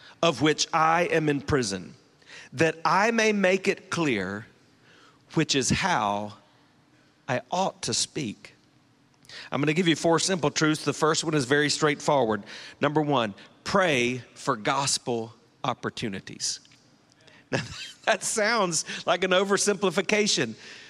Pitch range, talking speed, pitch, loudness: 140-185 Hz, 125 wpm, 155 Hz, -25 LUFS